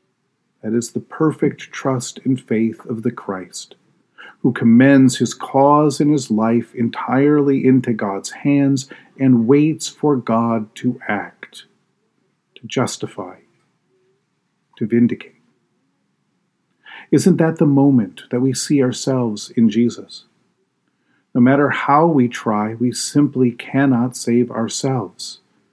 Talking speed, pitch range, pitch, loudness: 120 wpm, 120-145 Hz, 130 Hz, -17 LUFS